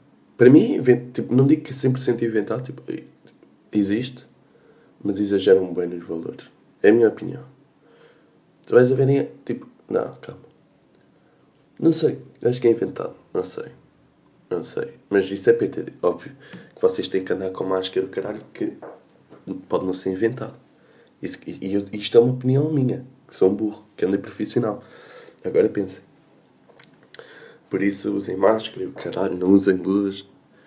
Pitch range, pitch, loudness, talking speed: 95-130 Hz, 115 Hz, -22 LUFS, 165 wpm